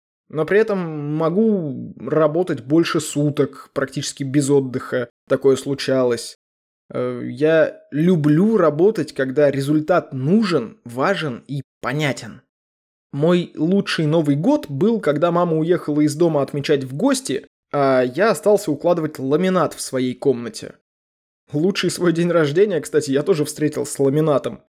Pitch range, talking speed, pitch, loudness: 135-170 Hz, 125 wpm, 150 Hz, -19 LUFS